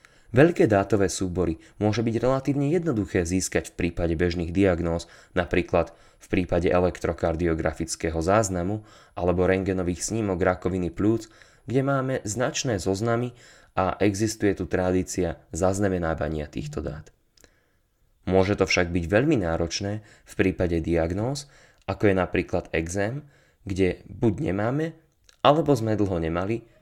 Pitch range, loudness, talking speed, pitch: 85-110 Hz, -25 LUFS, 120 wpm, 95 Hz